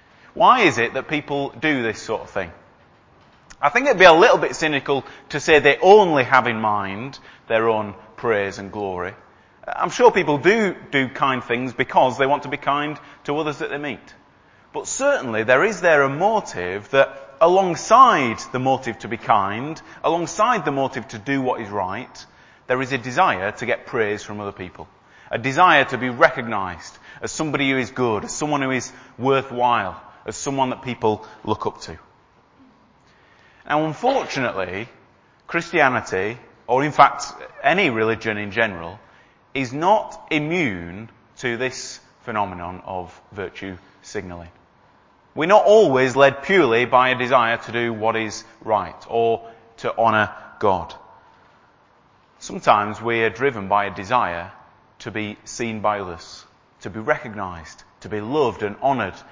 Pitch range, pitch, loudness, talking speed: 105-140 Hz, 120 Hz, -19 LUFS, 160 wpm